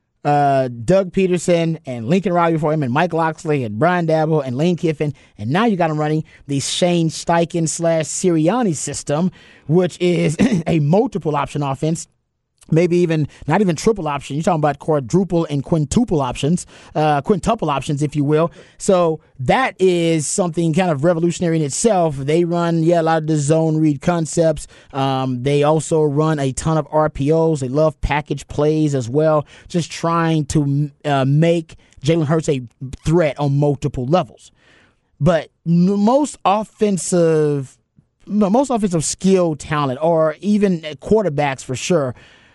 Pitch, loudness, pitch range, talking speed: 160 Hz, -18 LUFS, 145-175 Hz, 160 wpm